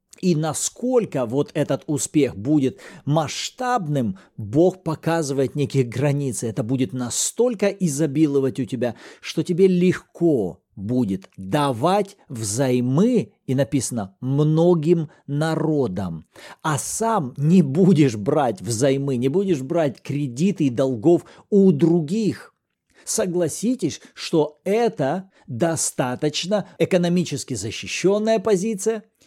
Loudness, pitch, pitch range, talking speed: -21 LUFS, 155 Hz, 135-180 Hz, 100 wpm